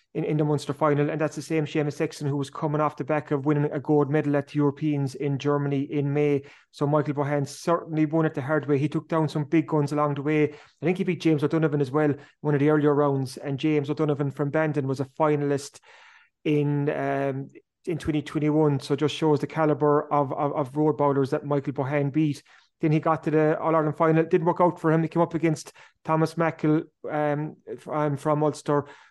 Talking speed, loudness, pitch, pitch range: 230 wpm, -25 LUFS, 150 Hz, 145-155 Hz